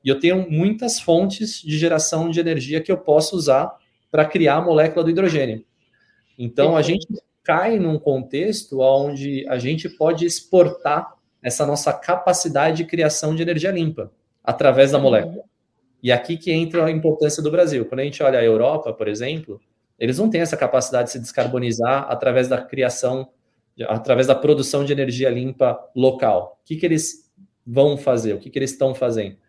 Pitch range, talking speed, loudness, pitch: 130-165 Hz, 180 wpm, -19 LUFS, 145 Hz